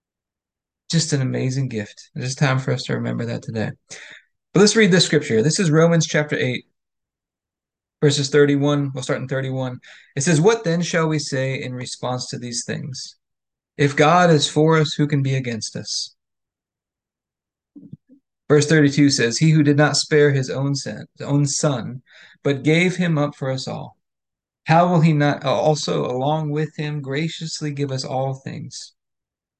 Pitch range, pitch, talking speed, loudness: 130-155 Hz, 145 Hz, 165 wpm, -19 LUFS